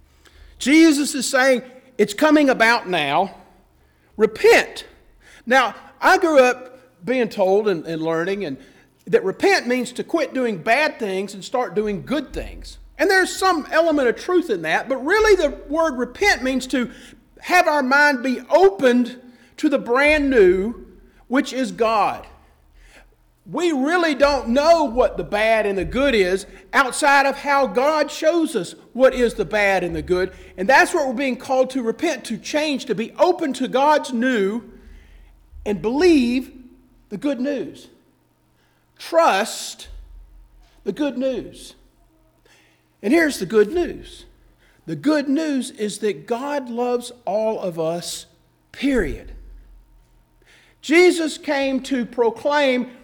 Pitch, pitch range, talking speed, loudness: 255 Hz, 205-290 Hz, 145 wpm, -19 LUFS